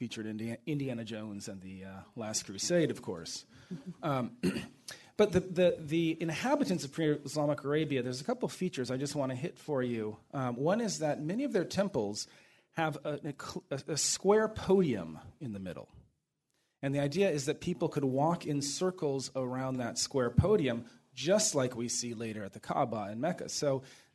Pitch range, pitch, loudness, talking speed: 125-170 Hz, 140 Hz, -33 LUFS, 180 wpm